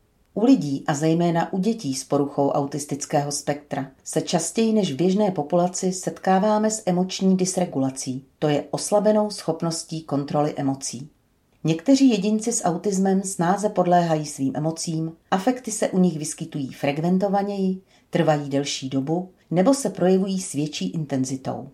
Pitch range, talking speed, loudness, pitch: 145-190 Hz, 135 wpm, -23 LUFS, 165 Hz